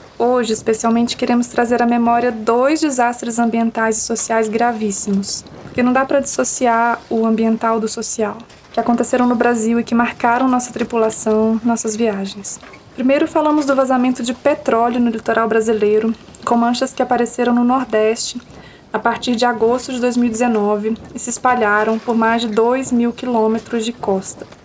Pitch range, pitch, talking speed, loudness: 225-245 Hz, 235 Hz, 155 wpm, -17 LUFS